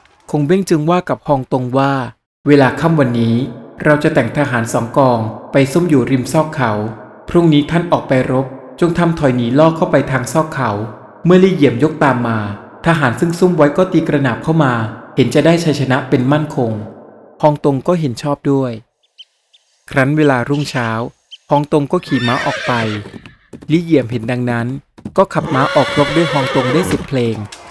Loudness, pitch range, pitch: -14 LUFS, 120-155 Hz, 140 Hz